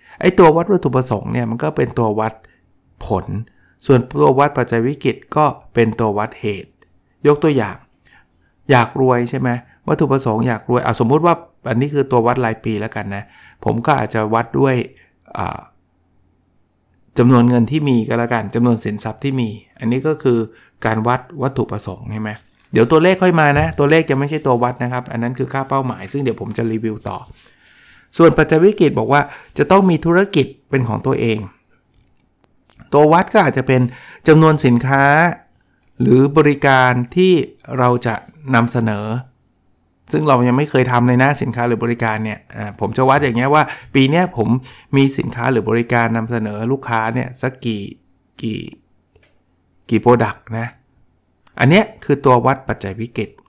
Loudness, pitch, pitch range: -16 LUFS, 125 Hz, 110-140 Hz